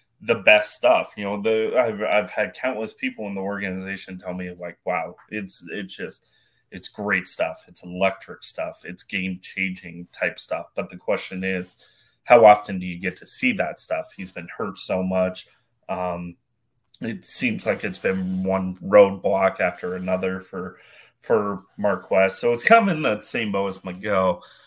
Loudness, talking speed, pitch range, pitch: -23 LUFS, 180 wpm, 95-105 Hz, 95 Hz